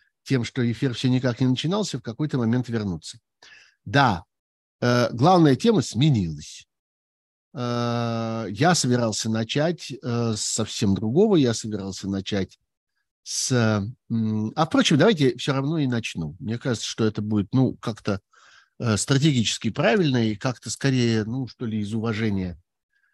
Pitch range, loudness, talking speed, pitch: 105-130 Hz, -23 LUFS, 125 wpm, 115 Hz